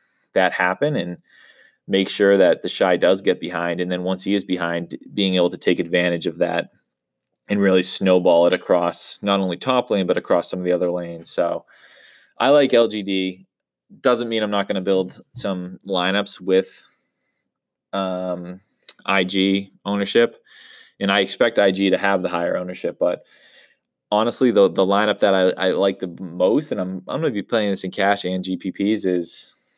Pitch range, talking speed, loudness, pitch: 90-100 Hz, 180 wpm, -20 LUFS, 95 Hz